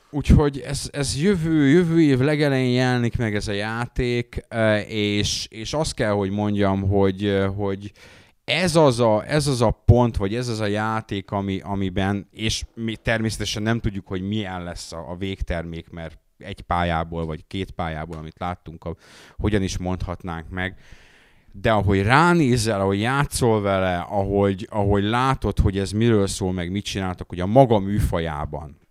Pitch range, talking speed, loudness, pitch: 90-115 Hz, 160 wpm, -22 LUFS, 100 Hz